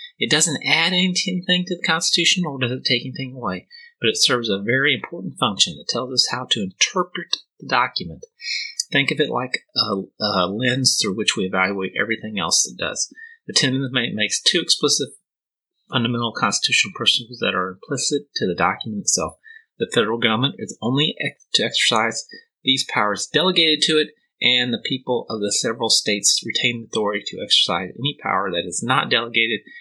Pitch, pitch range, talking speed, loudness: 135 Hz, 120-180 Hz, 180 wpm, -19 LUFS